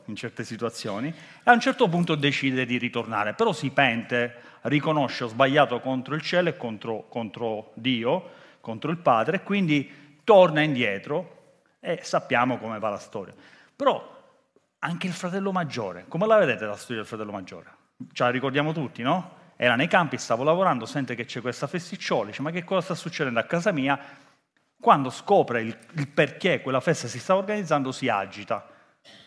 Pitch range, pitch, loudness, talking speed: 120-165 Hz, 135 Hz, -25 LUFS, 175 wpm